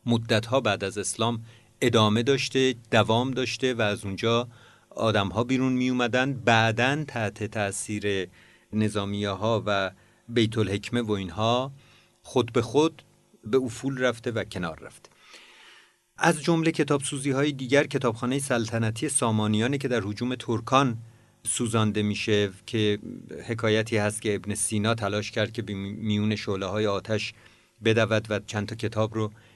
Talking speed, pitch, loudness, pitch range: 140 wpm, 115 Hz, -26 LUFS, 105-125 Hz